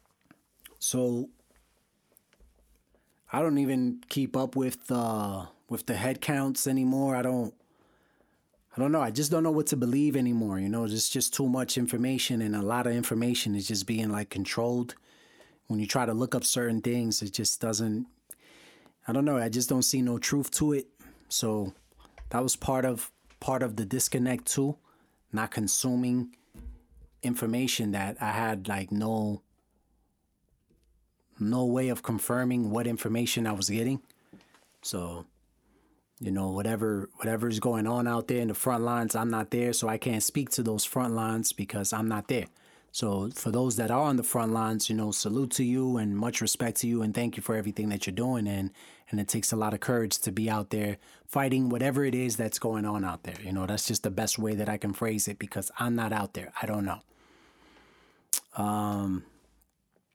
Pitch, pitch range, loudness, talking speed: 115 Hz, 105-125 Hz, -29 LUFS, 190 wpm